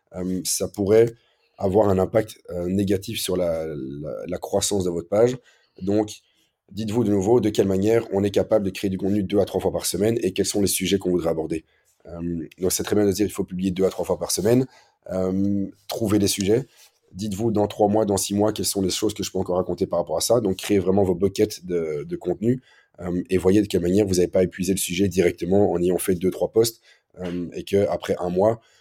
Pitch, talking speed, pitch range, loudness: 100 Hz, 245 wpm, 90-105 Hz, -23 LUFS